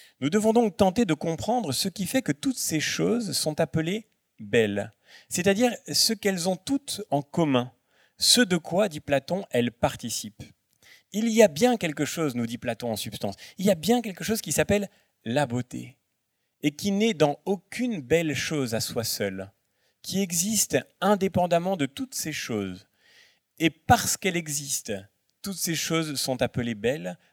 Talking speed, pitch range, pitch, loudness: 170 wpm, 125-205 Hz, 165 Hz, -26 LUFS